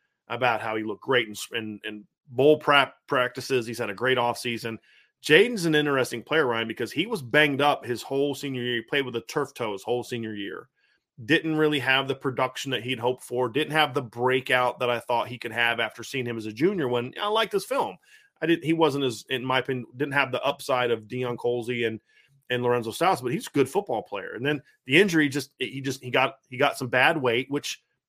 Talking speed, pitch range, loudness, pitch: 235 wpm, 120-145 Hz, -25 LUFS, 130 Hz